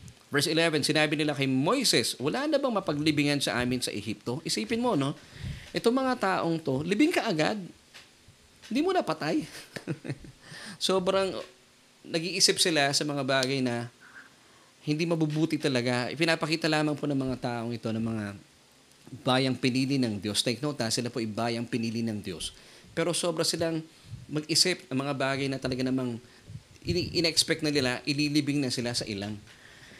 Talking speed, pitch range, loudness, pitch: 160 wpm, 125-165 Hz, -28 LUFS, 140 Hz